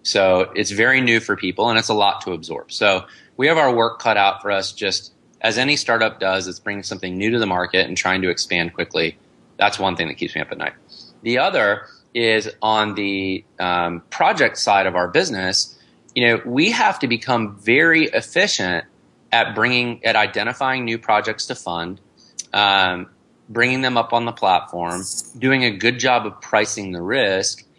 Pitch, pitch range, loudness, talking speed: 105 Hz, 95-115 Hz, -19 LUFS, 190 wpm